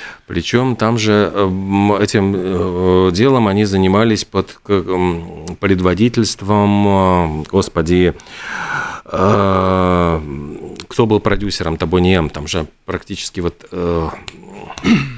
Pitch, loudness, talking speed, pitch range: 95 Hz, -15 LUFS, 70 wpm, 90-105 Hz